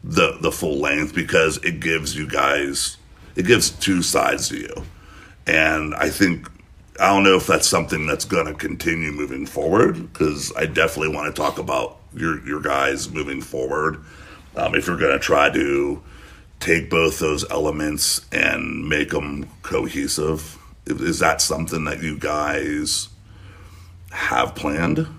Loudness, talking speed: -20 LUFS, 155 wpm